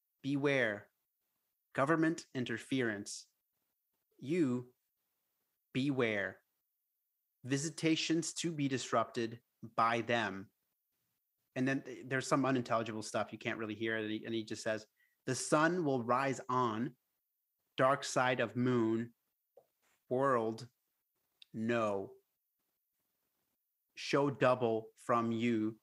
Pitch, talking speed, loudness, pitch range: 125 Hz, 95 wpm, -35 LUFS, 115-135 Hz